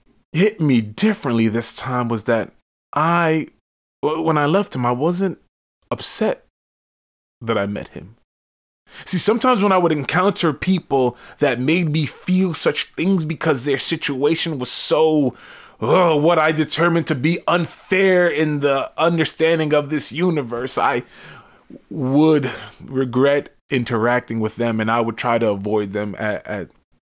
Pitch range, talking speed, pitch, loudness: 120-165 Hz, 145 wpm, 150 Hz, -18 LUFS